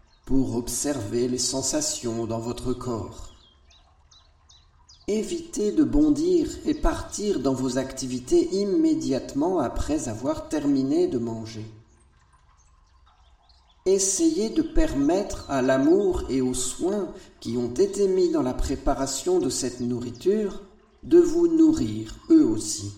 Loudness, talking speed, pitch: -24 LUFS, 115 wpm, 135 Hz